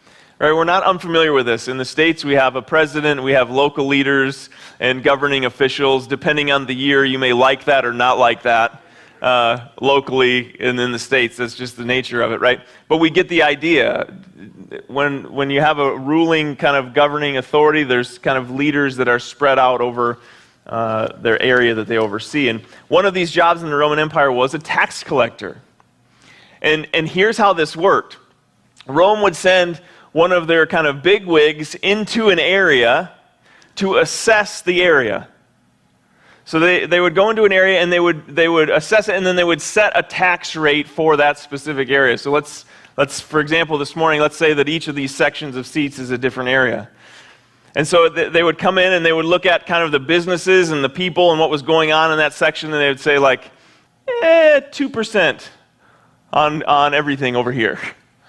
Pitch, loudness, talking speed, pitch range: 150 Hz, -15 LUFS, 200 wpm, 130-170 Hz